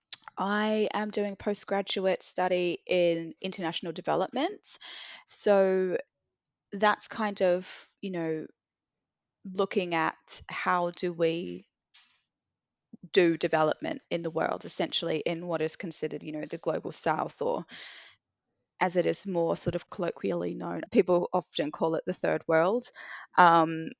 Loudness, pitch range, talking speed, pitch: -29 LUFS, 165-200 Hz, 130 wpm, 180 Hz